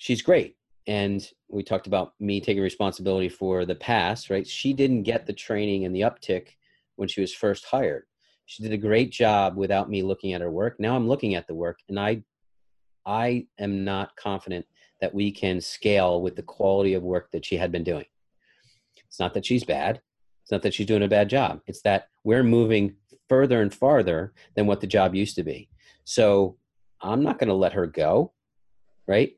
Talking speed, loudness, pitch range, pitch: 200 wpm, -25 LUFS, 95-105 Hz, 100 Hz